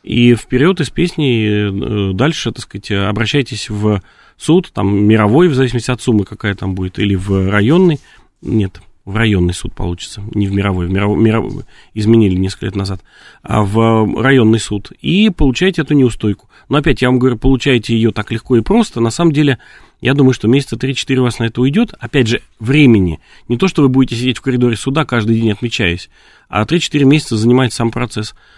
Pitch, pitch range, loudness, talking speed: 115 Hz, 105-135 Hz, -14 LUFS, 185 wpm